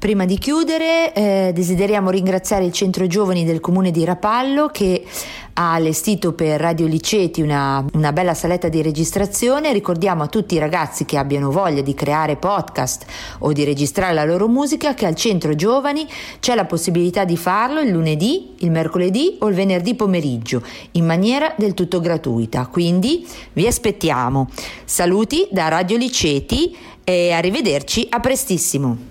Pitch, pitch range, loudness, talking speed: 180 Hz, 160-210 Hz, -18 LUFS, 155 wpm